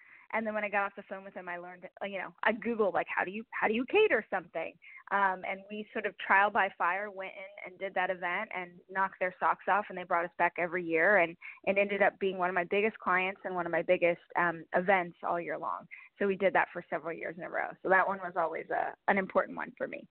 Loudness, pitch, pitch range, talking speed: -31 LUFS, 190 Hz, 175-205 Hz, 275 wpm